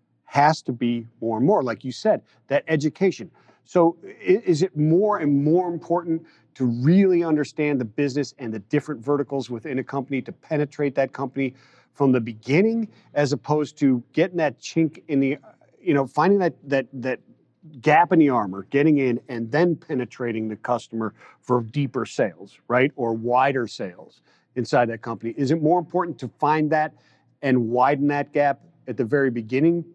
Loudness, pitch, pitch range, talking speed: -23 LUFS, 140 Hz, 125-155 Hz, 175 wpm